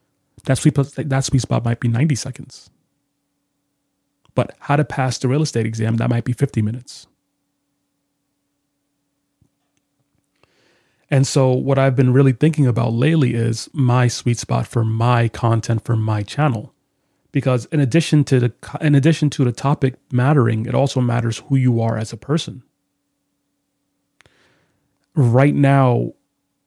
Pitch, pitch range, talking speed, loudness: 135 Hz, 120-145 Hz, 140 wpm, -18 LUFS